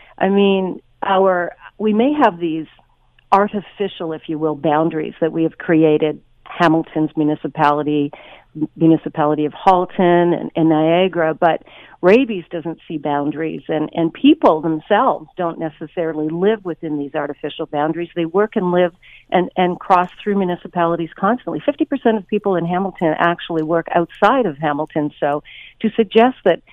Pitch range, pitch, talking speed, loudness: 155-195 Hz, 170 Hz, 145 wpm, -18 LUFS